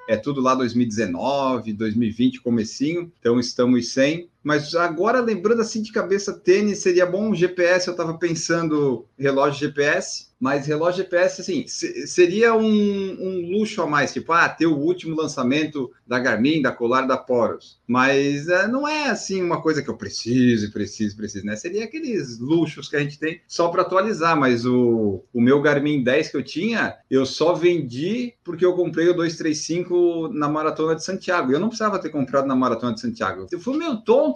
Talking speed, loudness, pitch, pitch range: 180 wpm, -21 LUFS, 160 Hz, 130-185 Hz